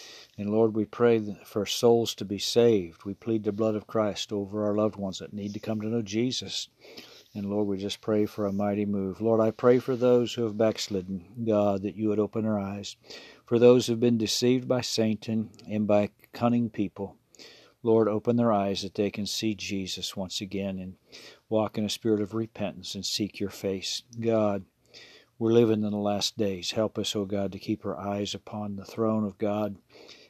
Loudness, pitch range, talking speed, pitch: -28 LUFS, 100-115 Hz, 210 wpm, 105 Hz